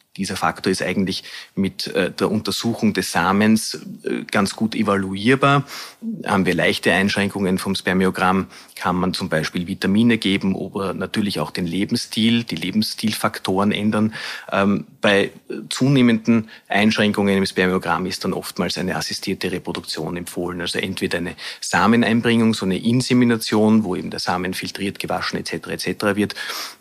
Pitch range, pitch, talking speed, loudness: 90-110 Hz, 100 Hz, 135 wpm, -20 LUFS